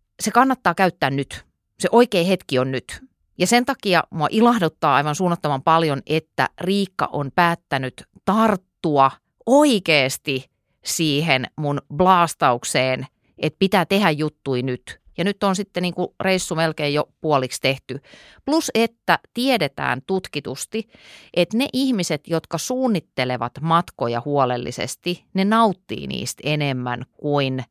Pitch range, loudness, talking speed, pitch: 135-195 Hz, -20 LUFS, 125 wpm, 160 Hz